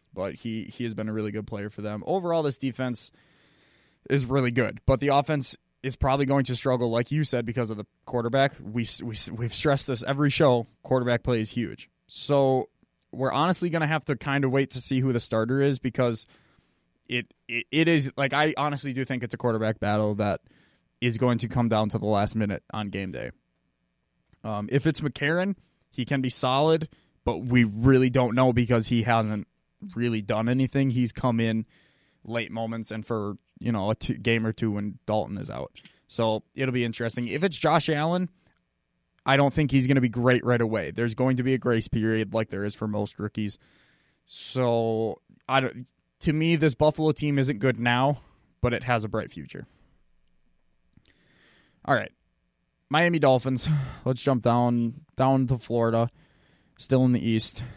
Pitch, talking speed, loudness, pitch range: 125 Hz, 190 wpm, -26 LUFS, 110-135 Hz